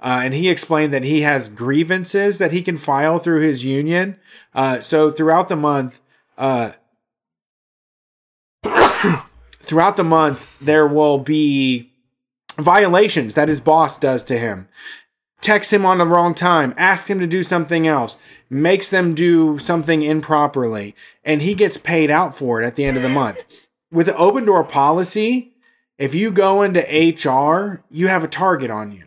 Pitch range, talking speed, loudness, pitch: 135-185 Hz, 165 wpm, -16 LUFS, 155 Hz